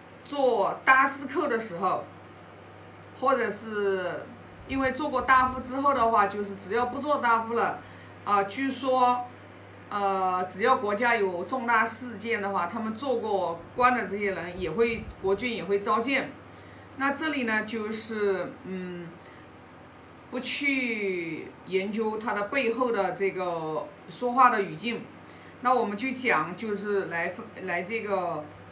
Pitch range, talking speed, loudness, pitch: 190-250 Hz, 200 characters per minute, -27 LUFS, 220 Hz